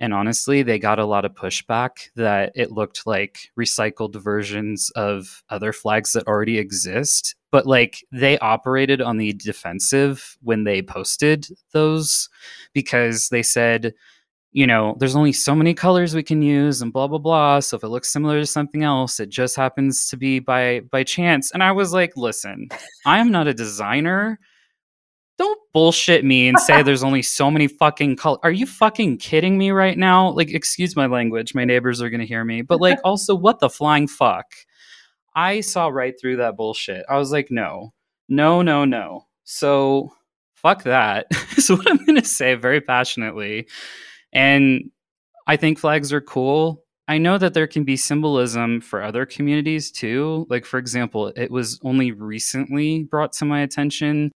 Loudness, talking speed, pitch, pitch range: -19 LUFS, 180 wpm, 135 Hz, 120-155 Hz